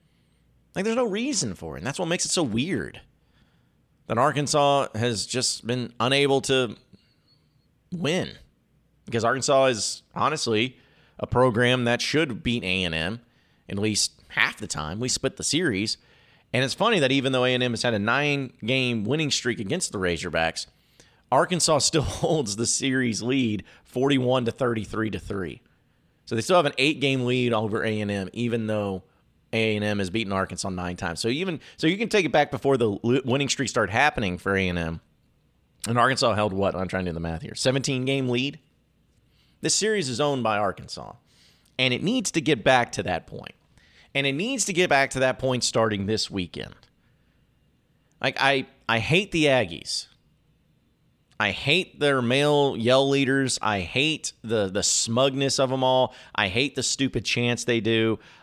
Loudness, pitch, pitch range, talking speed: -24 LUFS, 125 Hz, 110-140 Hz, 175 wpm